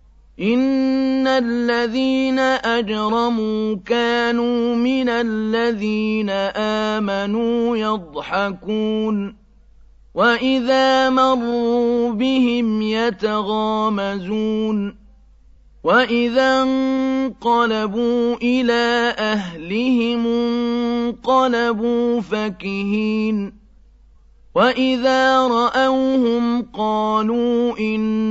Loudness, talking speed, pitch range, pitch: -18 LUFS, 50 wpm, 215-240 Hz, 235 Hz